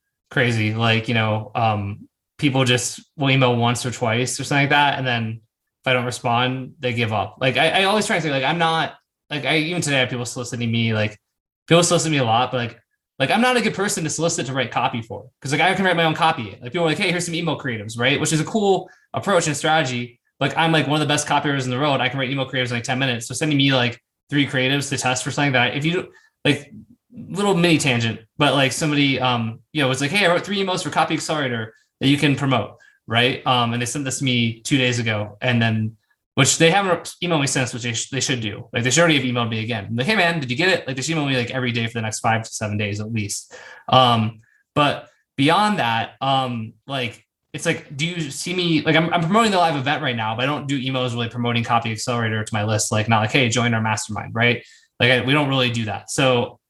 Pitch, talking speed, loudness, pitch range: 130 Hz, 270 wpm, -20 LUFS, 120-155 Hz